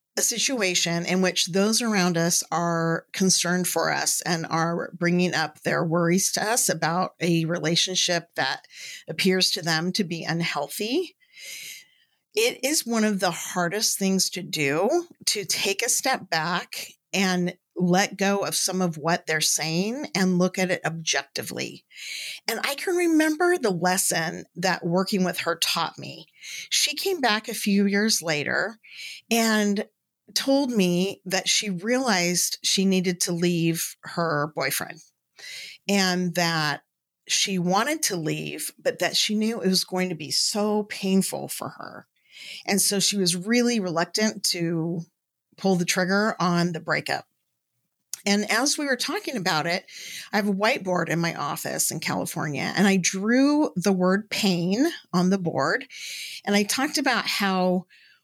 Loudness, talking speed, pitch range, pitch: -24 LUFS, 155 wpm, 175-215 Hz, 185 Hz